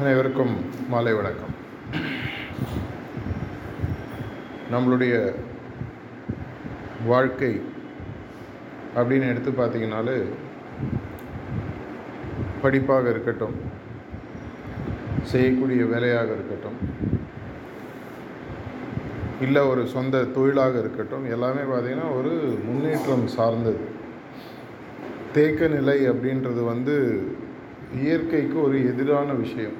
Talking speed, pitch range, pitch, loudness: 60 wpm, 115-135 Hz, 125 Hz, -25 LUFS